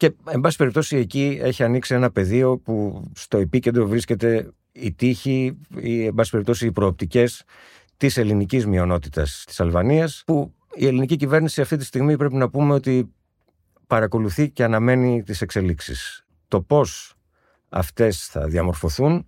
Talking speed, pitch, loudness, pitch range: 145 wpm, 125 Hz, -21 LUFS, 105-140 Hz